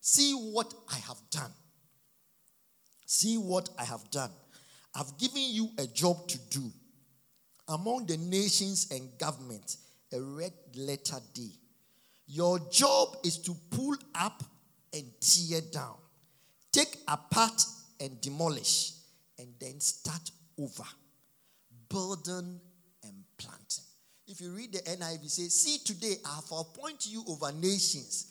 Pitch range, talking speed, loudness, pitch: 145-195 Hz, 130 wpm, -31 LUFS, 170 Hz